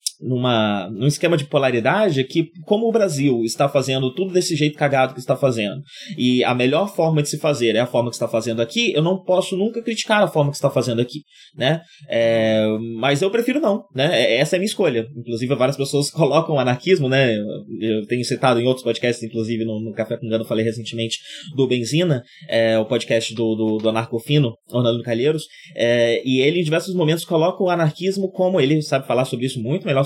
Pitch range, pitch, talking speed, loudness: 115-160 Hz, 135 Hz, 210 wpm, -20 LUFS